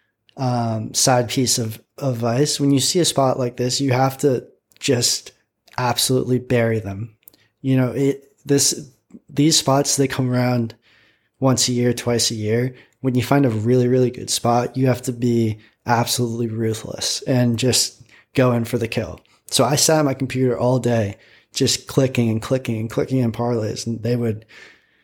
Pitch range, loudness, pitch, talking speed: 115-130 Hz, -19 LUFS, 125 Hz, 180 wpm